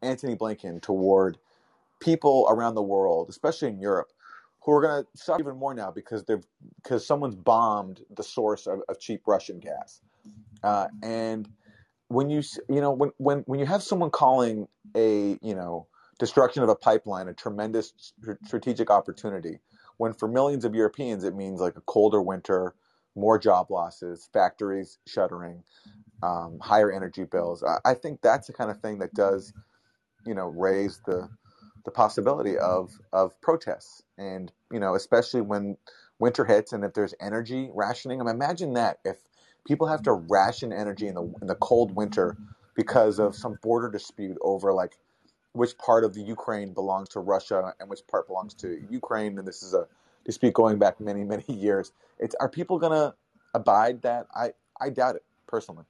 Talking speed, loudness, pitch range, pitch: 175 wpm, -26 LUFS, 95-120 Hz, 105 Hz